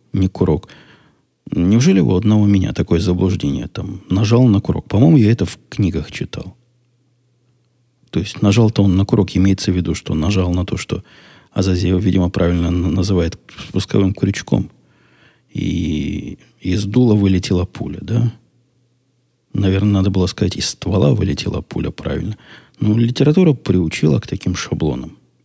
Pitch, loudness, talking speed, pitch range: 95 Hz, -17 LUFS, 140 wpm, 90-115 Hz